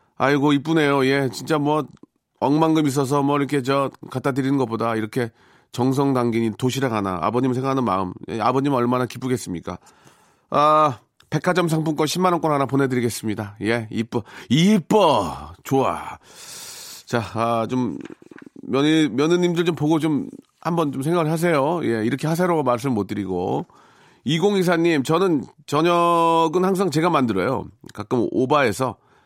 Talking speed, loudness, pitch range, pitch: 300 characters per minute, -21 LUFS, 125-165 Hz, 140 Hz